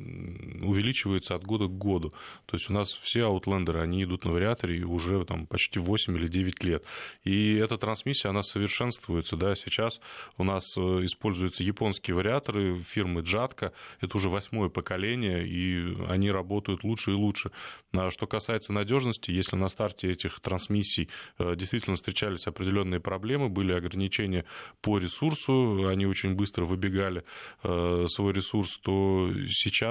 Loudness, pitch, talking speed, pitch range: -30 LUFS, 95 Hz, 140 wpm, 90-105 Hz